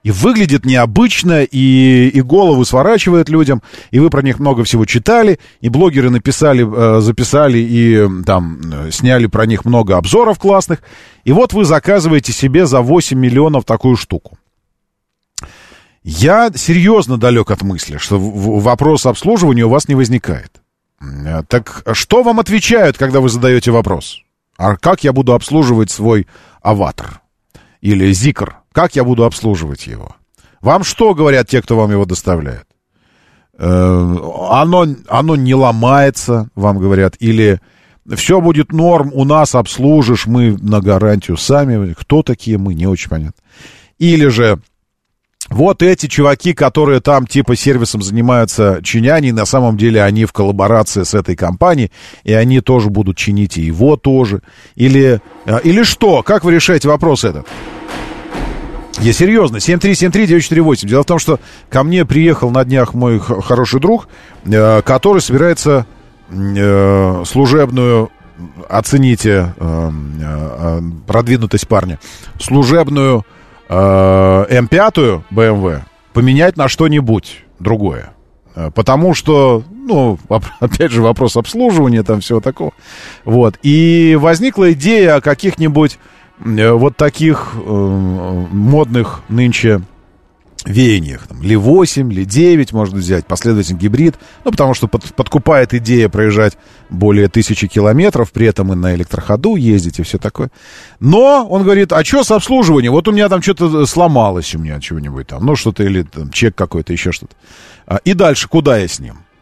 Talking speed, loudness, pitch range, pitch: 135 wpm, -11 LUFS, 100-150 Hz, 120 Hz